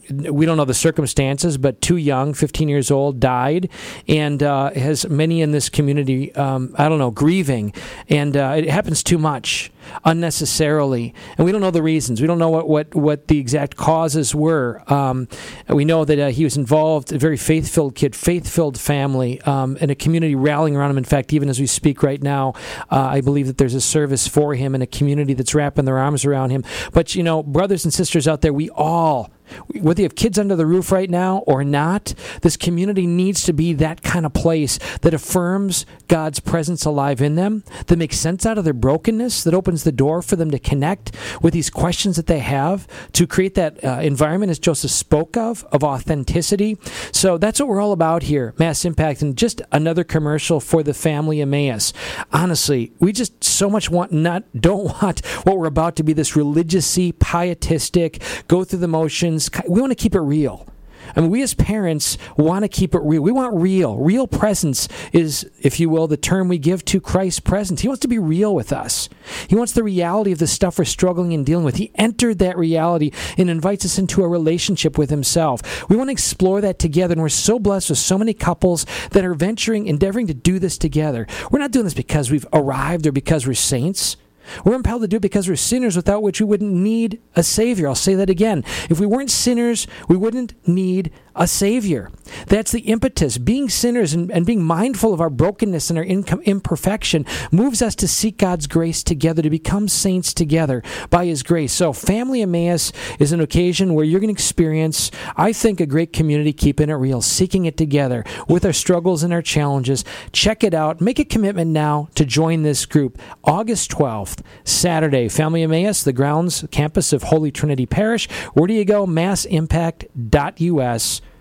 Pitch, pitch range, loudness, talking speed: 165 Hz, 145-185 Hz, -18 LUFS, 205 wpm